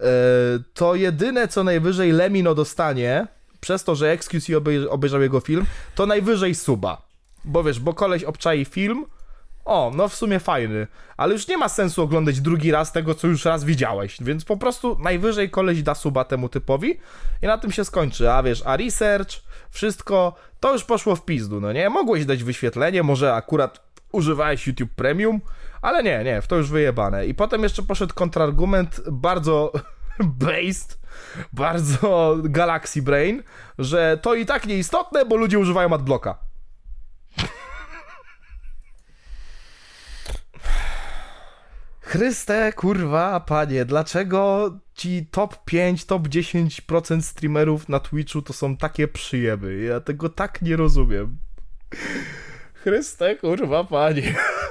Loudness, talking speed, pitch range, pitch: -21 LUFS, 135 wpm, 140-190 Hz, 160 Hz